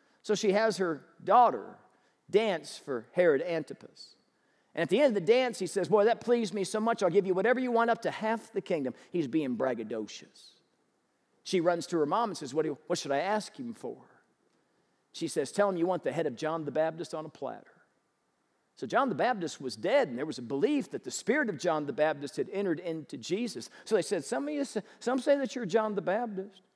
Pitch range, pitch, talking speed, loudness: 160-230 Hz, 195 Hz, 235 wpm, -30 LUFS